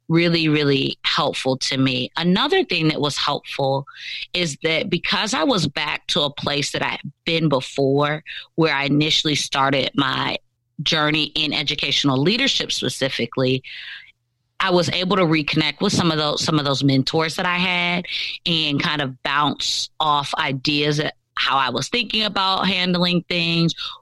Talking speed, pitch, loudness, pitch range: 160 wpm, 155 Hz, -20 LUFS, 140-175 Hz